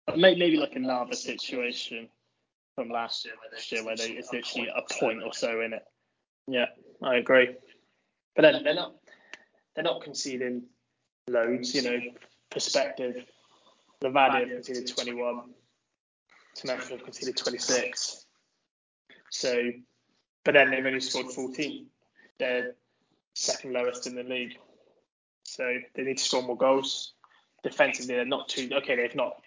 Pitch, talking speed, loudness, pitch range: 125 Hz, 145 wpm, -28 LUFS, 120-130 Hz